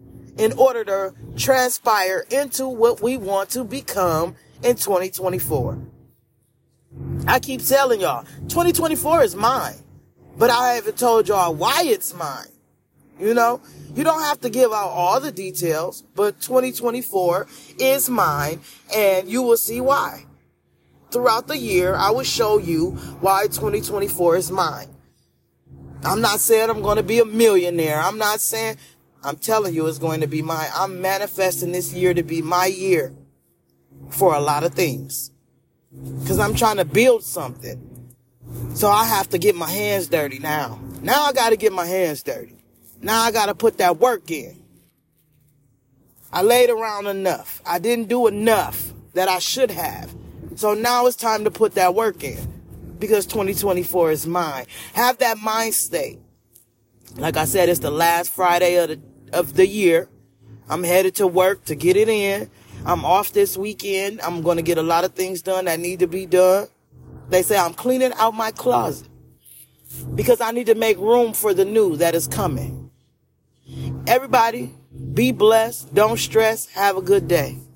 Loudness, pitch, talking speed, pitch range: -19 LUFS, 185 Hz, 165 wpm, 150-225 Hz